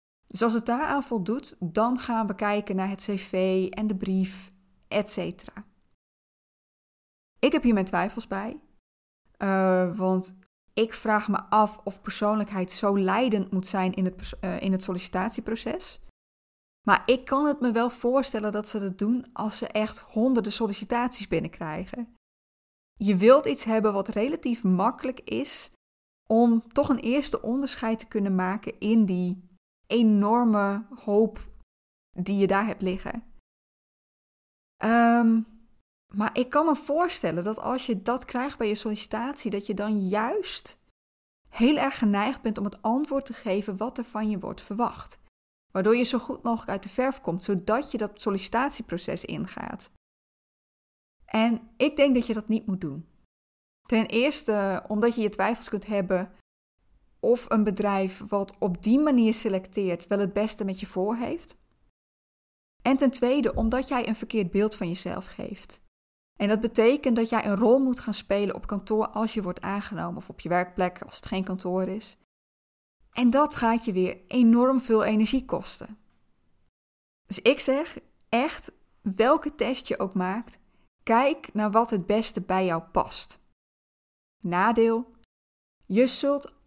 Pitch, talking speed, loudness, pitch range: 215 Hz, 160 wpm, -26 LUFS, 195-235 Hz